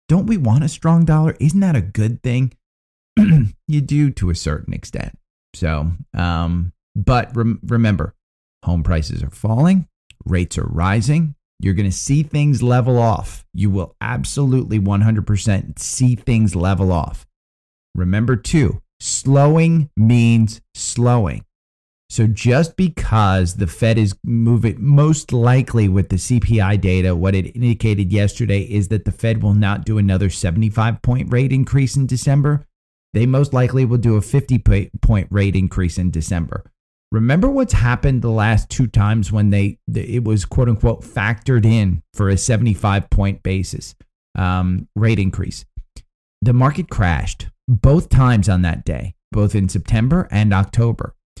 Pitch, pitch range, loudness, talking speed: 110 Hz, 95-125 Hz, -17 LUFS, 150 wpm